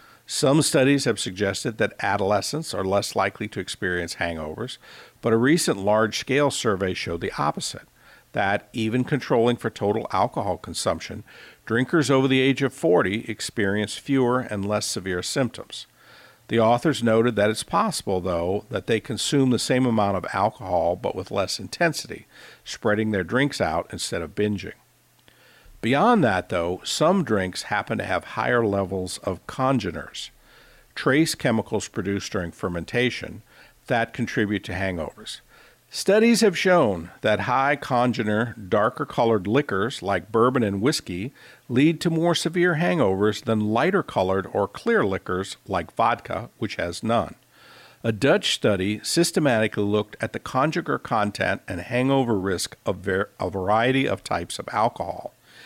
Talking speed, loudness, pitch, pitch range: 145 wpm, -23 LUFS, 115 Hz, 100-135 Hz